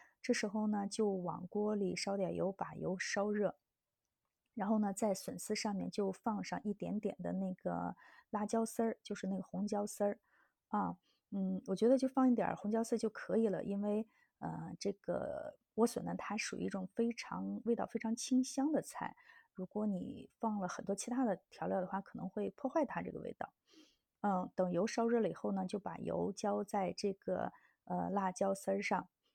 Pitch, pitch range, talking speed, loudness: 205 Hz, 195-230 Hz, 265 characters per minute, -39 LUFS